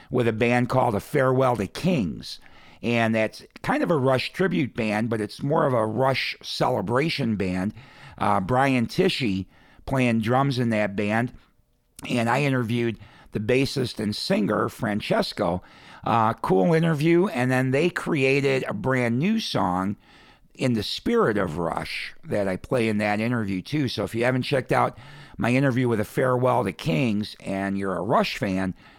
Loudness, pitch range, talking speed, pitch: -24 LUFS, 105-135 Hz, 170 wpm, 125 Hz